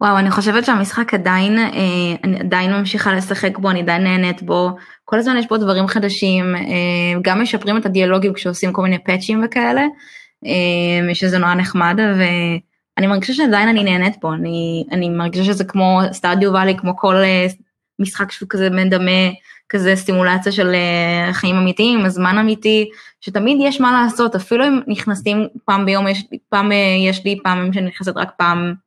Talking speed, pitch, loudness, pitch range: 160 wpm, 195 Hz, -16 LUFS, 185-210 Hz